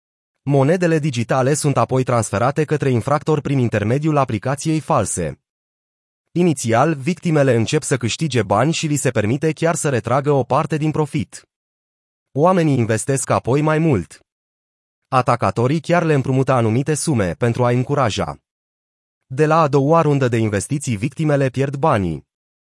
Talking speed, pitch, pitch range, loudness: 135 wpm, 135 Hz, 115-155 Hz, -18 LUFS